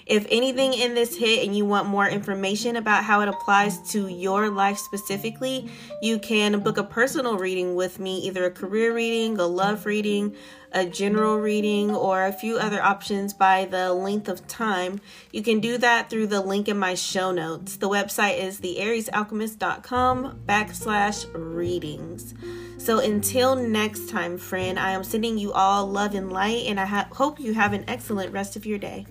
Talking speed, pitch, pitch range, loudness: 180 wpm, 205 Hz, 190-220 Hz, -24 LUFS